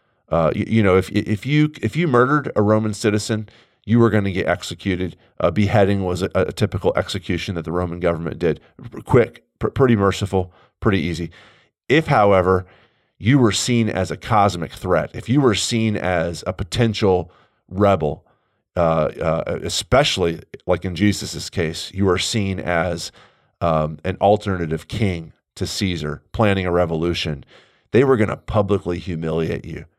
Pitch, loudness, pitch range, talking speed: 95 Hz, -20 LUFS, 85-105 Hz, 160 wpm